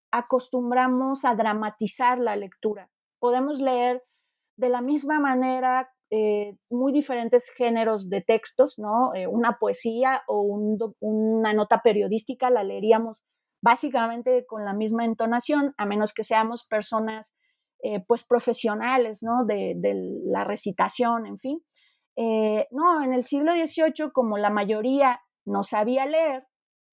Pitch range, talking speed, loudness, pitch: 220-260 Hz, 135 wpm, -24 LUFS, 240 Hz